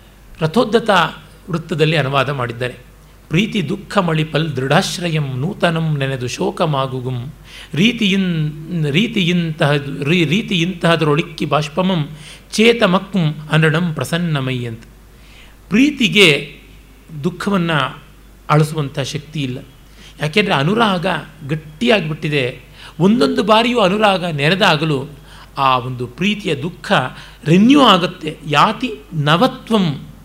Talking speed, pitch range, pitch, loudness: 80 wpm, 145-190 Hz, 160 Hz, -16 LUFS